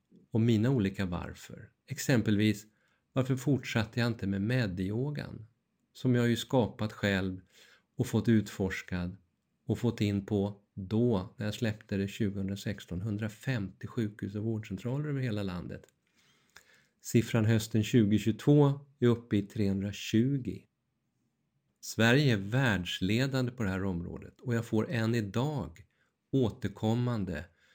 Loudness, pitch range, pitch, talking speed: -31 LUFS, 100-120 Hz, 110 Hz, 120 wpm